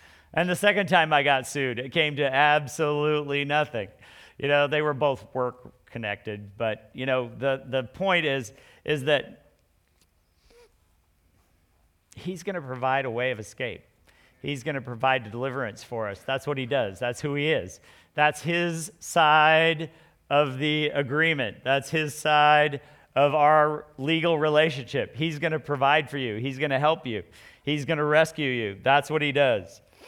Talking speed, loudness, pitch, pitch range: 160 wpm, -25 LUFS, 145 Hz, 130-155 Hz